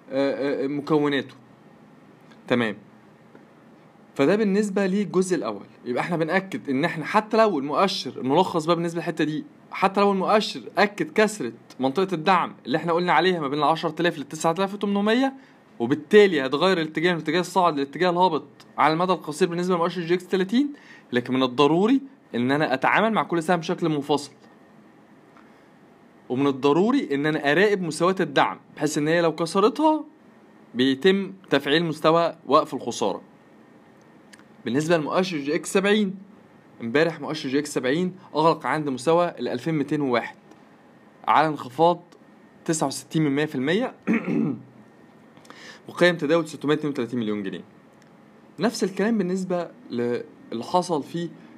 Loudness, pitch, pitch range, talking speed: -23 LUFS, 170 Hz, 145-190 Hz, 125 wpm